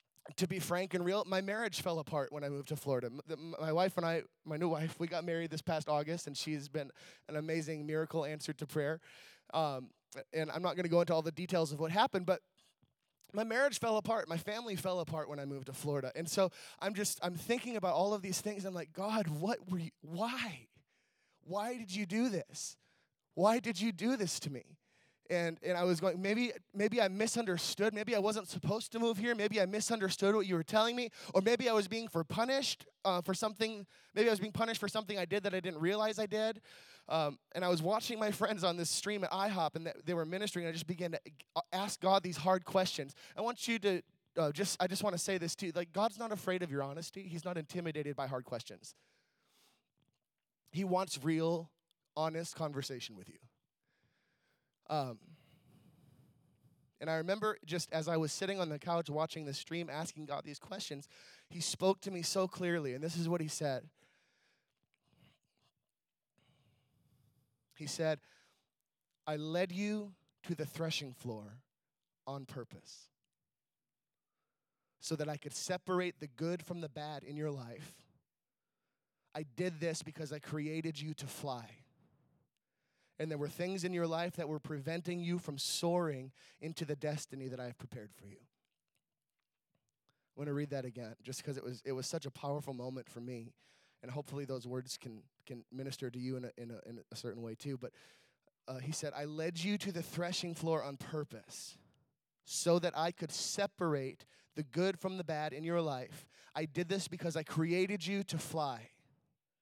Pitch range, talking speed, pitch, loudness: 145-190 Hz, 195 wpm, 165 Hz, -38 LUFS